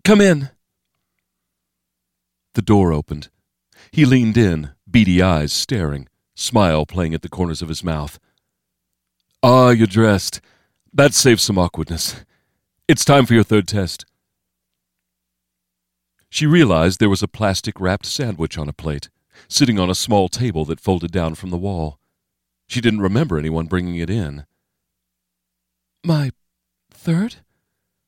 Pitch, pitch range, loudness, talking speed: 90 Hz, 75-110 Hz, -17 LUFS, 135 wpm